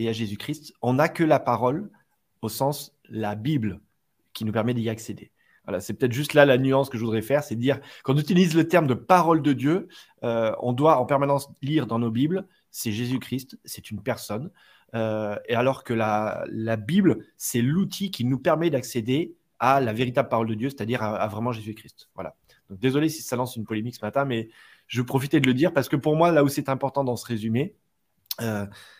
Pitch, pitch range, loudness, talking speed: 130 Hz, 115-145 Hz, -24 LUFS, 215 wpm